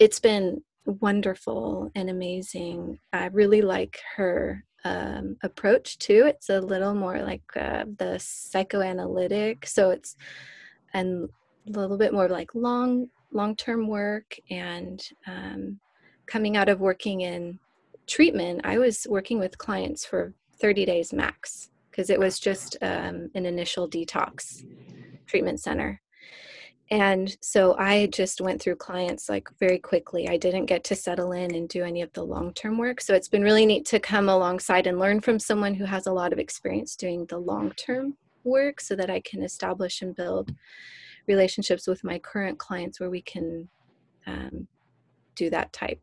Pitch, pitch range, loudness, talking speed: 190 Hz, 180-210 Hz, -26 LUFS, 160 wpm